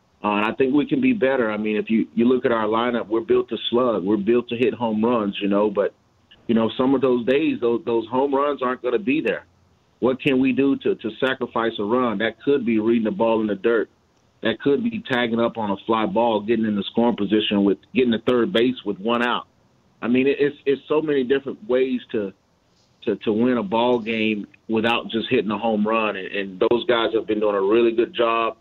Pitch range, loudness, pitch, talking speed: 110-125 Hz, -21 LUFS, 115 Hz, 245 wpm